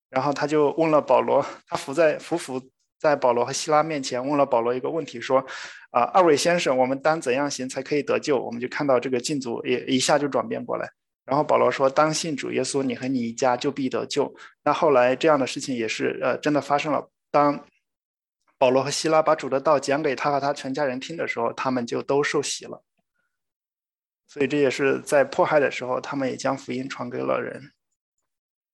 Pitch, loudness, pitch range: 140 Hz, -23 LUFS, 130-150 Hz